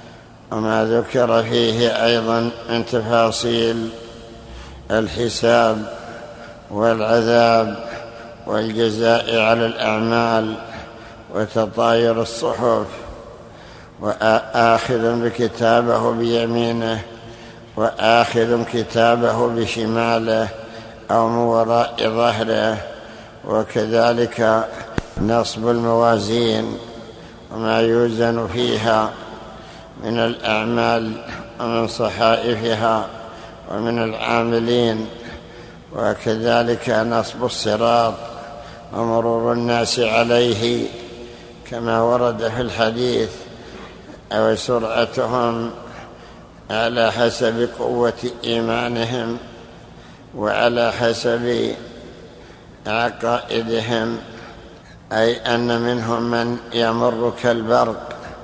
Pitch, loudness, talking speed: 115 Hz, -19 LUFS, 60 wpm